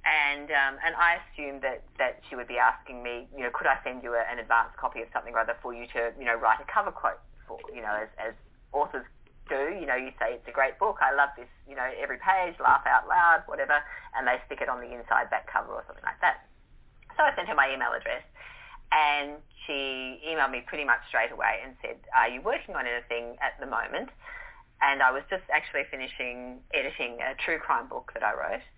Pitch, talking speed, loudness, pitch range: 135 Hz, 230 wpm, -28 LUFS, 120-165 Hz